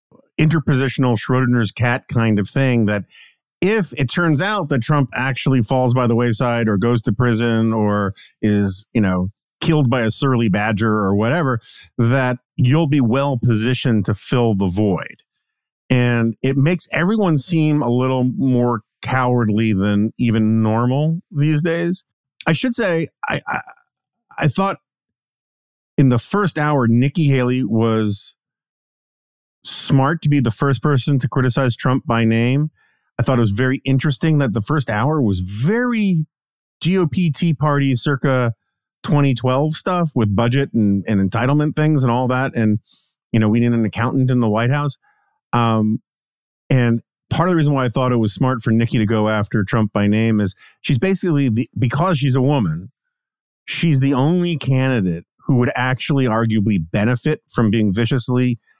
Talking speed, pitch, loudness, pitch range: 160 wpm, 130 Hz, -18 LUFS, 115-145 Hz